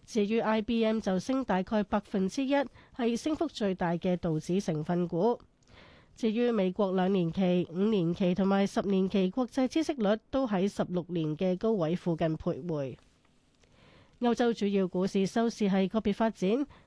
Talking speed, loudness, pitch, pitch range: 245 characters per minute, -30 LUFS, 195 Hz, 180-230 Hz